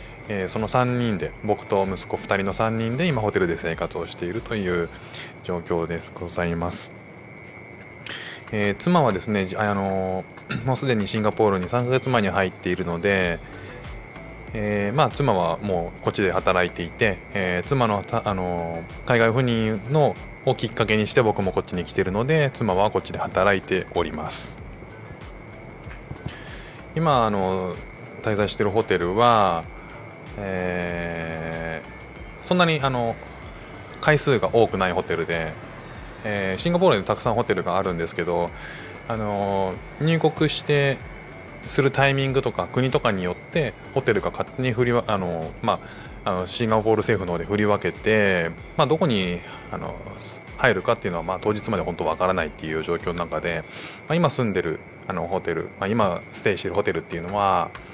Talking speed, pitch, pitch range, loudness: 320 characters per minute, 100 Hz, 90-120 Hz, -23 LUFS